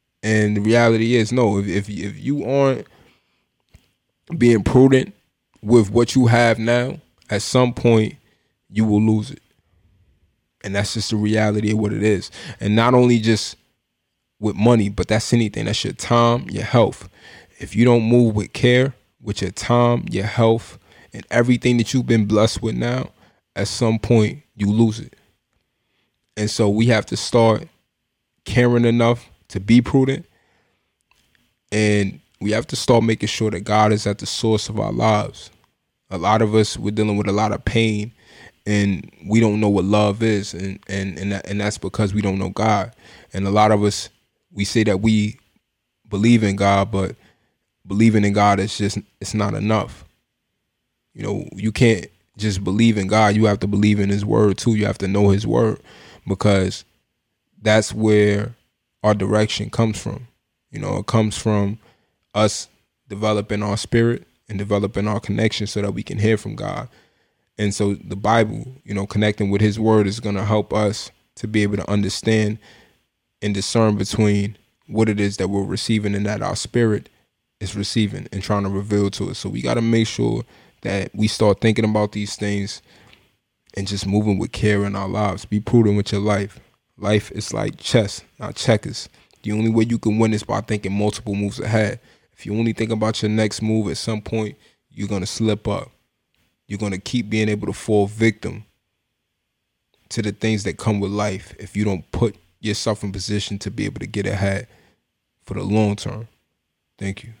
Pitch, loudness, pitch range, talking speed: 105 Hz, -19 LUFS, 100-115 Hz, 185 wpm